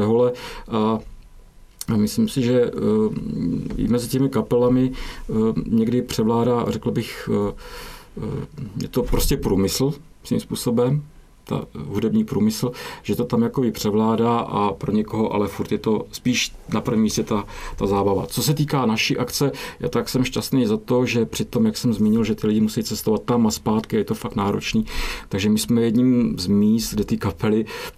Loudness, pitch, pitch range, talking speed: -22 LUFS, 115 Hz, 110-125 Hz, 170 wpm